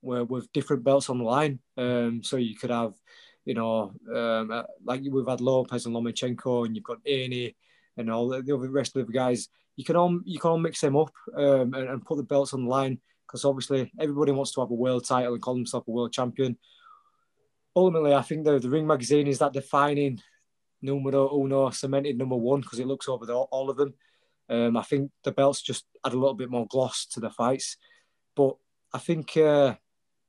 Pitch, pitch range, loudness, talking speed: 135 Hz, 125-145 Hz, -27 LUFS, 215 wpm